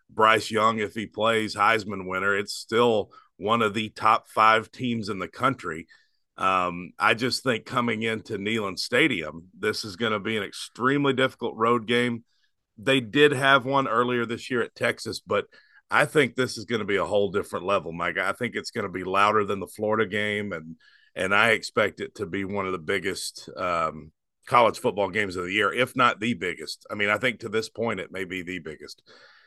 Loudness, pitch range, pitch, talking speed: -25 LUFS, 100-120 Hz, 110 Hz, 210 wpm